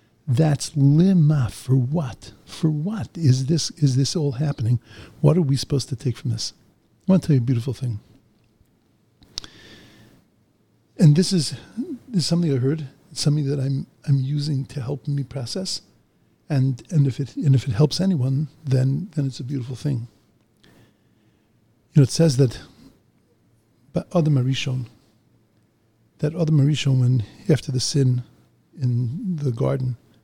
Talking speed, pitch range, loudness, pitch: 155 wpm, 115-150 Hz, -22 LUFS, 135 Hz